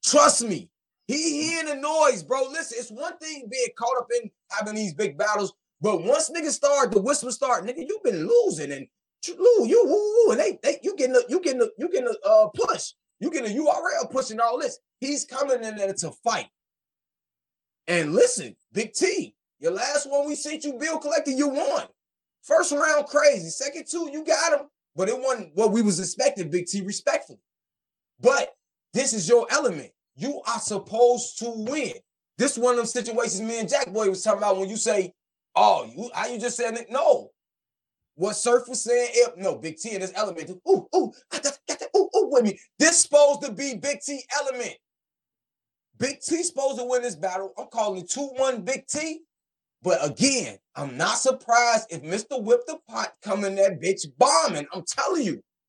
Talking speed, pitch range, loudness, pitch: 205 wpm, 220-305 Hz, -24 LUFS, 260 Hz